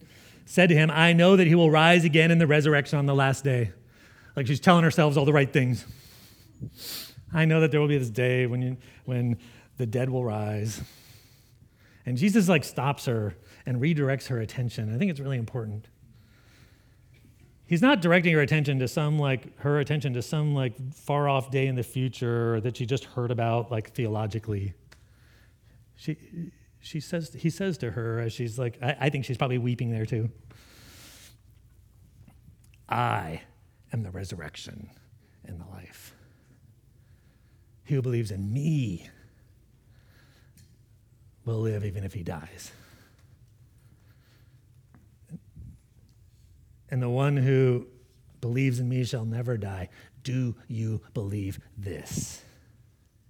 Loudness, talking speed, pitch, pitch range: -26 LUFS, 145 wpm, 120 Hz, 110-135 Hz